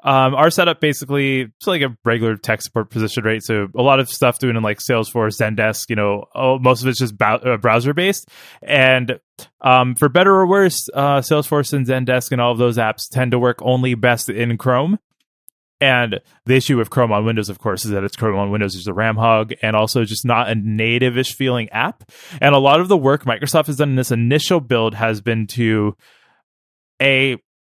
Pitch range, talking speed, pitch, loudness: 110-135 Hz, 210 wpm, 125 Hz, -17 LUFS